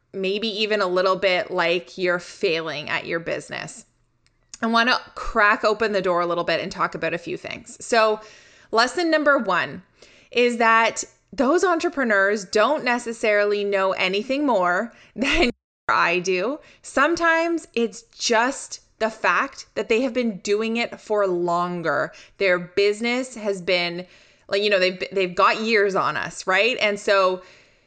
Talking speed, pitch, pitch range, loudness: 155 wpm, 215 Hz, 190-240 Hz, -21 LUFS